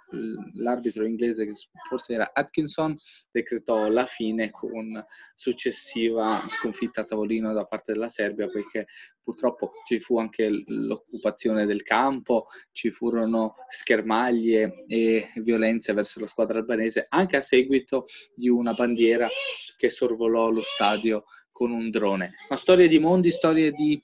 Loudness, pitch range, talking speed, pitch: -25 LUFS, 110-125 Hz, 135 wpm, 115 Hz